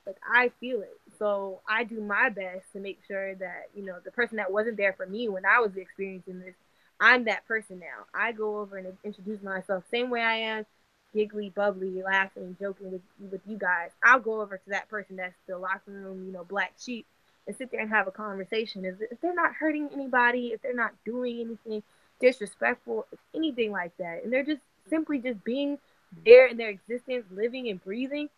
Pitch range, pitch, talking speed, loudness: 190-240 Hz, 215 Hz, 215 wpm, -27 LUFS